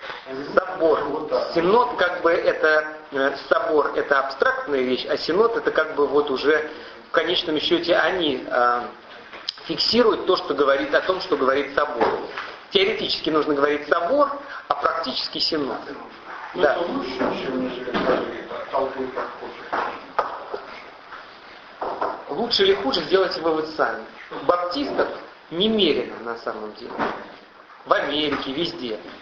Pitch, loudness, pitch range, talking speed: 160 Hz, -22 LUFS, 145-215 Hz, 115 wpm